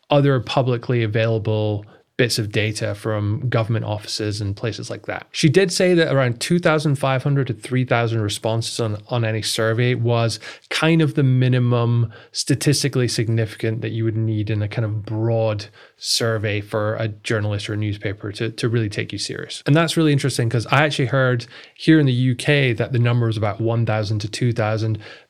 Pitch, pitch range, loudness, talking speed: 115 Hz, 110-130 Hz, -20 LUFS, 180 wpm